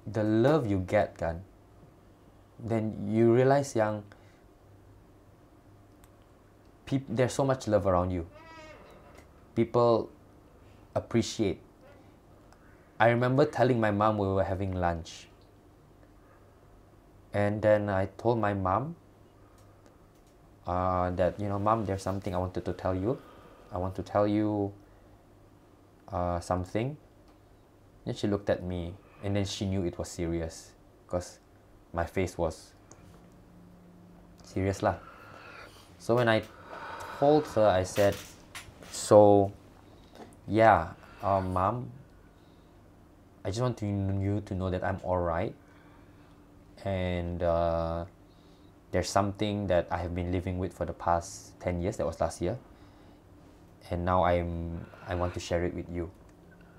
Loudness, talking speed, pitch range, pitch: -29 LUFS, 125 wpm, 90-105 Hz, 100 Hz